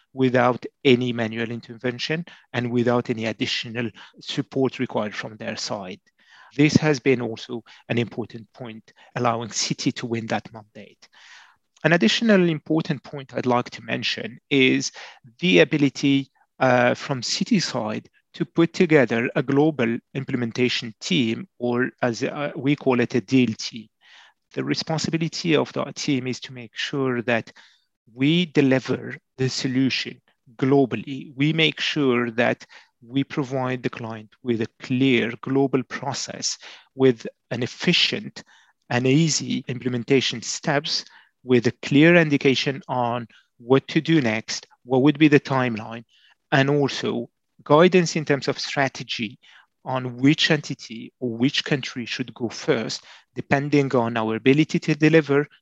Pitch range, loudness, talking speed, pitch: 120-145 Hz, -22 LUFS, 140 wpm, 130 Hz